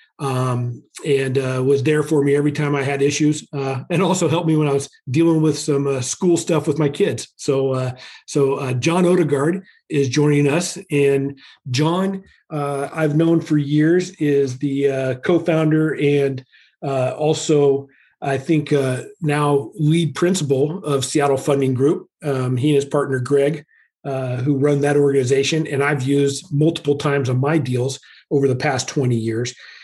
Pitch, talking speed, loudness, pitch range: 145 Hz, 175 wpm, -19 LUFS, 135-155 Hz